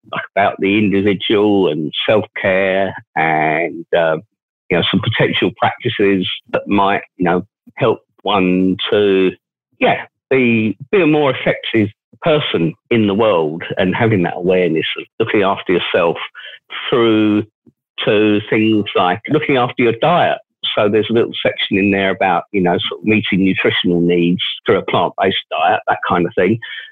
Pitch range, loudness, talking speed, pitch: 95-110 Hz, -15 LUFS, 160 wpm, 100 Hz